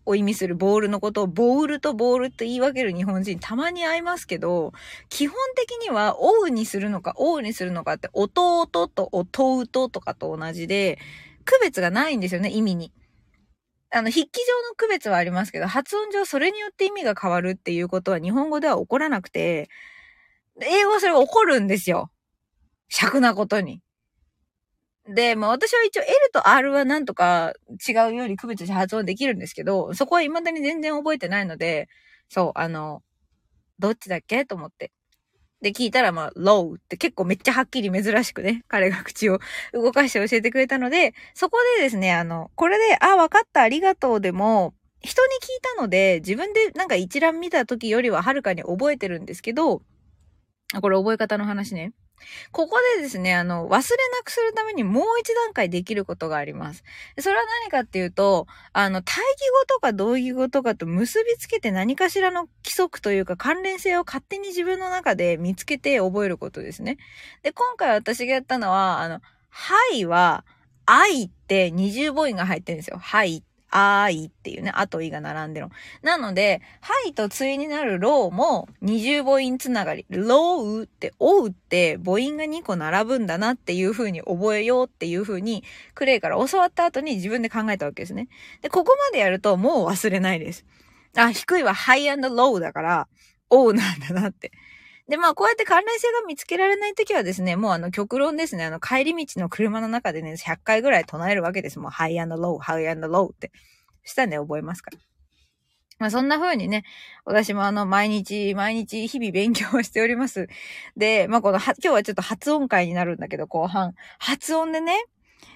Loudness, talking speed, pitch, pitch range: -22 LUFS, 370 characters per minute, 225 Hz, 190-300 Hz